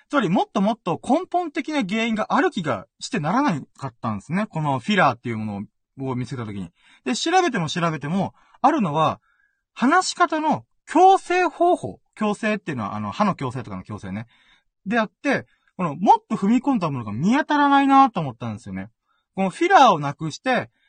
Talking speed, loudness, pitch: 390 characters per minute, -21 LUFS, 200 Hz